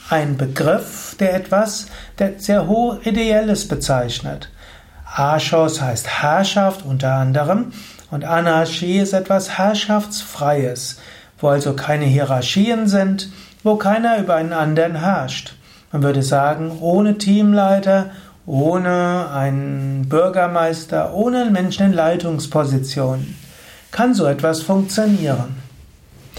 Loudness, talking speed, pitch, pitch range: -17 LUFS, 105 wpm, 165 Hz, 140-195 Hz